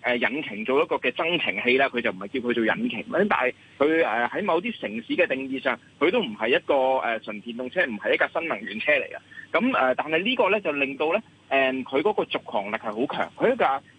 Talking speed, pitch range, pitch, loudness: 330 characters per minute, 120-155 Hz, 130 Hz, -24 LUFS